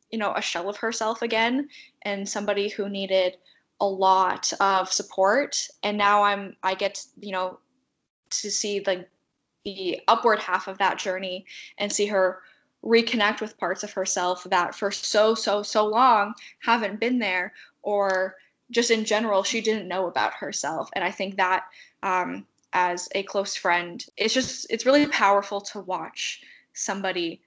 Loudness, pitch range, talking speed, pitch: -24 LUFS, 185-215 Hz, 165 wpm, 200 Hz